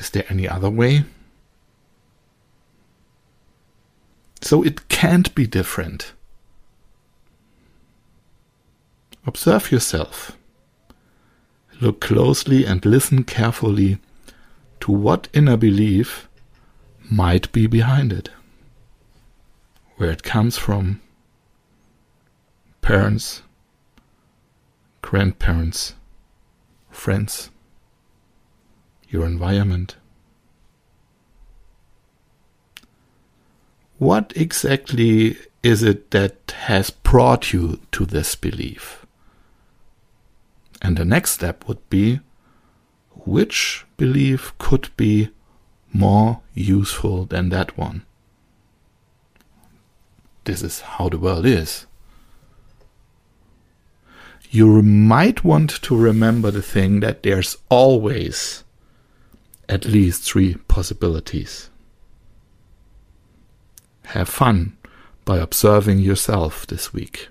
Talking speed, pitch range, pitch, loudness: 80 wpm, 95-115 Hz, 105 Hz, -18 LUFS